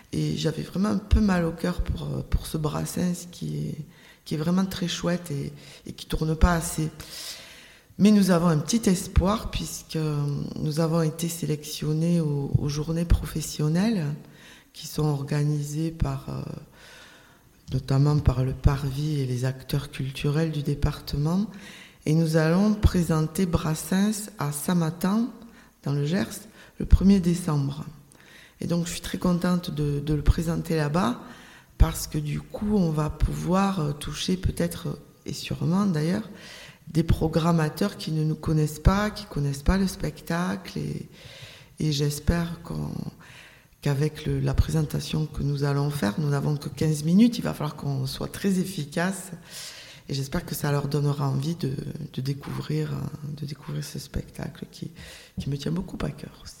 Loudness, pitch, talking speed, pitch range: -26 LUFS, 155 Hz, 155 wpm, 145-175 Hz